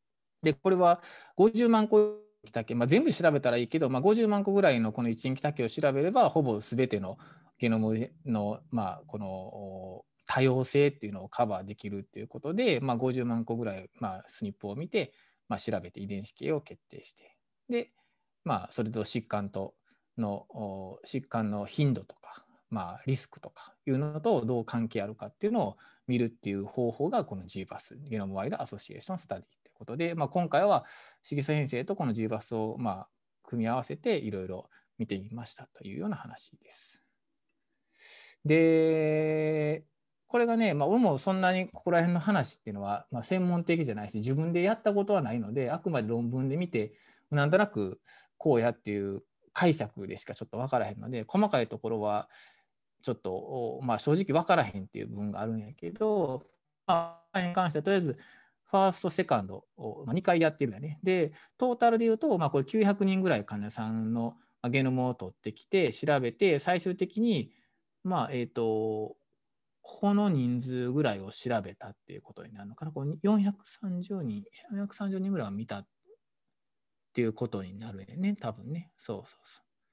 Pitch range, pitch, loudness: 110-180 Hz, 135 Hz, -30 LUFS